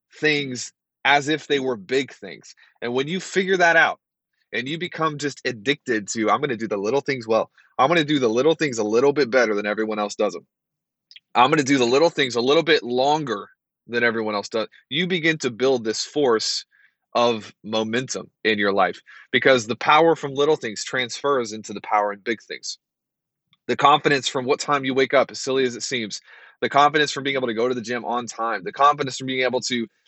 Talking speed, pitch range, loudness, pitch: 225 wpm, 115-145 Hz, -21 LUFS, 130 Hz